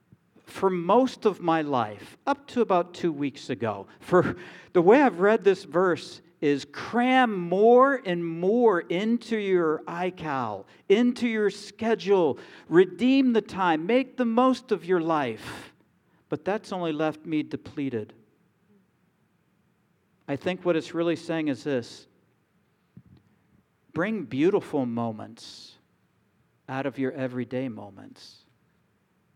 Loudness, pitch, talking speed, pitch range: -25 LUFS, 175 Hz, 125 wpm, 145-210 Hz